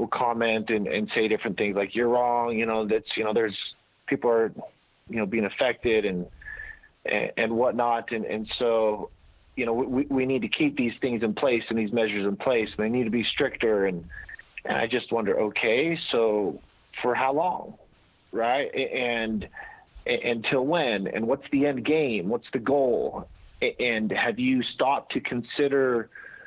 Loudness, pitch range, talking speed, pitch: -26 LUFS, 110-140 Hz, 175 wpm, 120 Hz